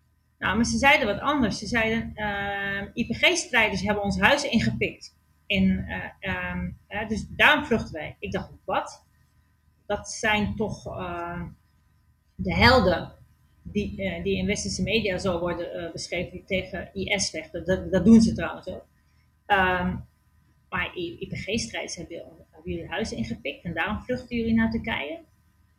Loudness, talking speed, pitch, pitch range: -25 LUFS, 145 wpm, 200 Hz, 180-225 Hz